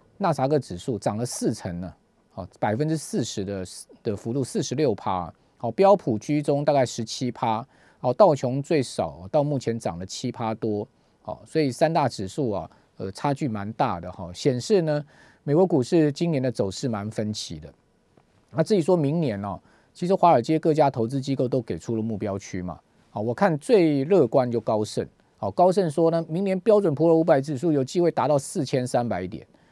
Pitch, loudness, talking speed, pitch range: 130 Hz, -24 LUFS, 280 characters per minute, 110-160 Hz